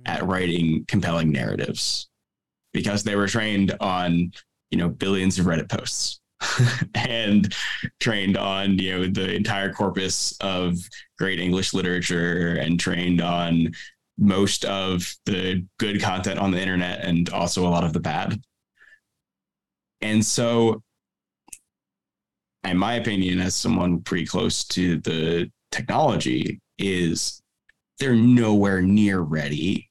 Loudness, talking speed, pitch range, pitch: -23 LUFS, 125 wpm, 85-100 Hz, 95 Hz